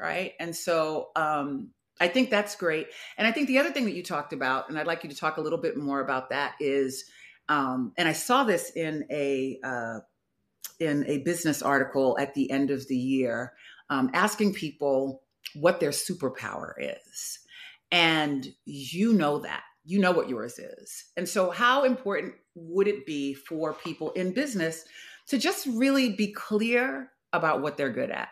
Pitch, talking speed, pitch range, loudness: 160 Hz, 180 wpm, 140-205 Hz, -28 LUFS